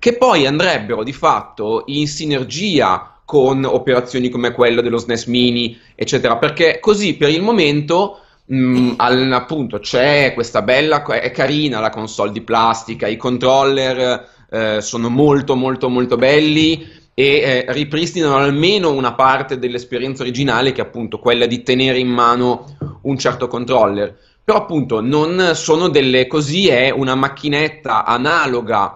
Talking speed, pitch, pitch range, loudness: 140 wpm, 130 Hz, 120-150 Hz, -15 LUFS